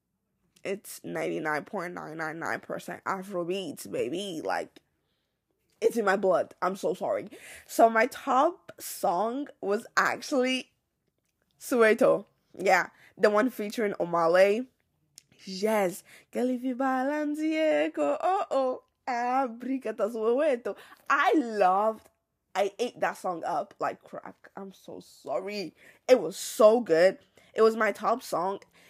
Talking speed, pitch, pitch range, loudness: 100 wpm, 230 Hz, 205-265 Hz, -28 LUFS